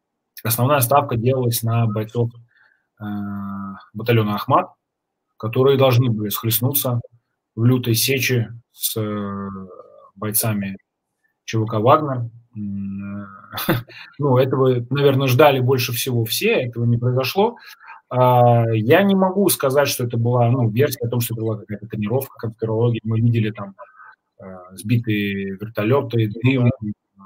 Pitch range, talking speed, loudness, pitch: 105-130 Hz, 115 wpm, -19 LUFS, 115 Hz